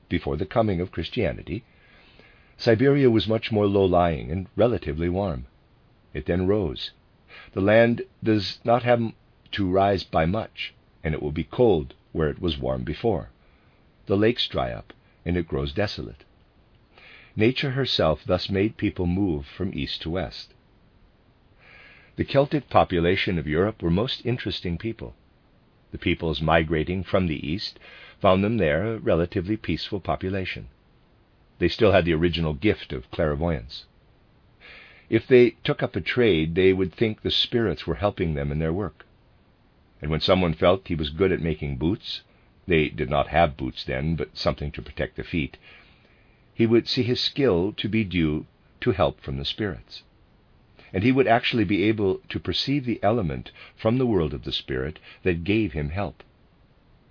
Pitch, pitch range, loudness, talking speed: 95 Hz, 80-110 Hz, -24 LUFS, 165 wpm